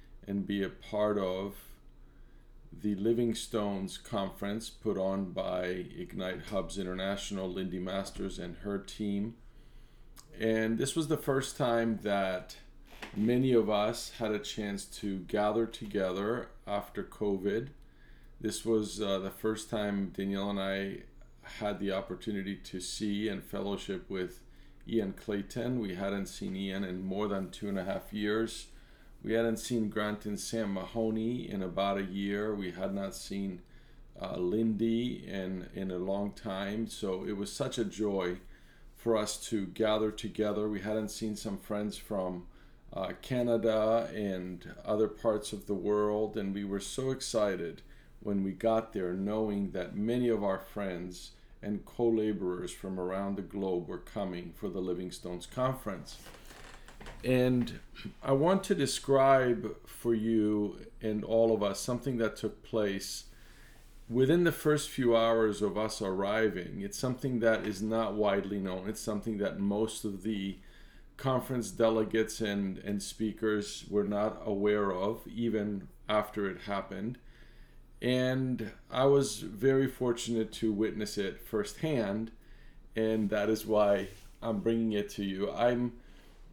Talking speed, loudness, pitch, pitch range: 145 wpm, -33 LUFS, 105 Hz, 100-115 Hz